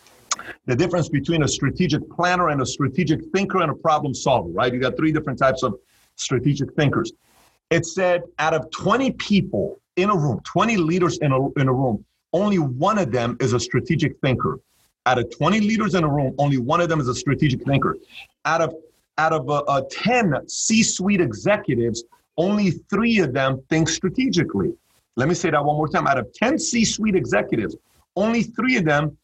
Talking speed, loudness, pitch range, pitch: 190 wpm, -21 LUFS, 140-185 Hz, 160 Hz